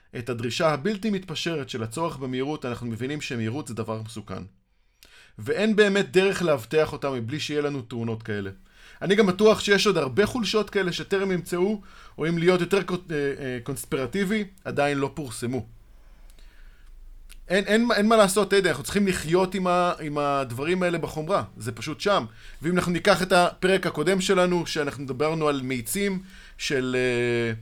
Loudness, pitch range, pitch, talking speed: -25 LUFS, 130-190 Hz, 155 Hz, 155 wpm